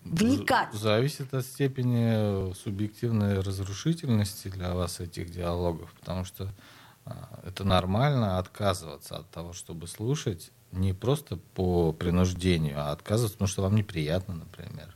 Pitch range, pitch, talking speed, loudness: 90-120 Hz, 100 Hz, 120 wpm, -29 LUFS